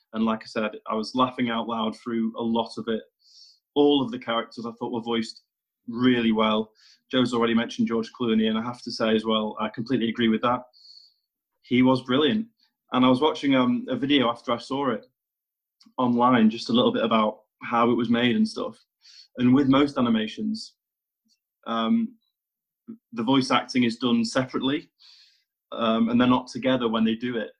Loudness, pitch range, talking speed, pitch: -24 LUFS, 115-135 Hz, 190 wpm, 120 Hz